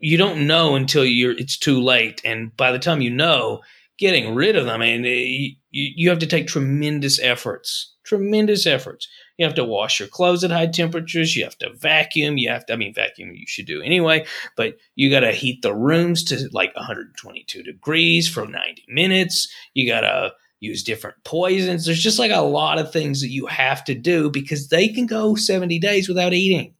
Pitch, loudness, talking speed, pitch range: 160 Hz, -19 LUFS, 210 wpm, 135-180 Hz